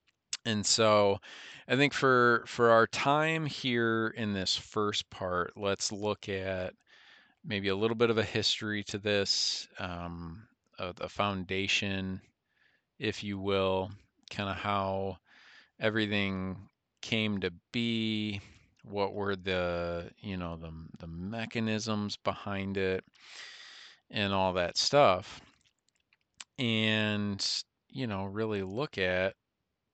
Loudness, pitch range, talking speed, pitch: -31 LUFS, 95-110 Hz, 120 wpm, 100 Hz